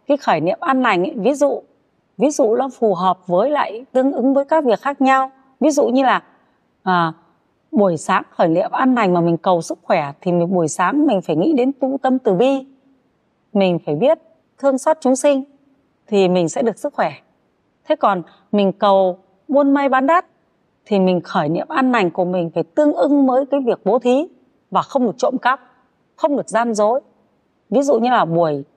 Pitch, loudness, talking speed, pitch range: 255 Hz, -17 LUFS, 210 wpm, 190-275 Hz